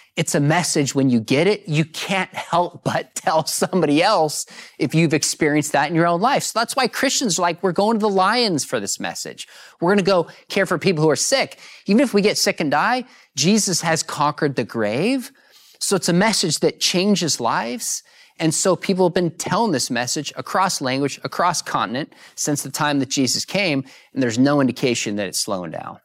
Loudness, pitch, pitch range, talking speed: -19 LUFS, 170 Hz, 145-195 Hz, 210 wpm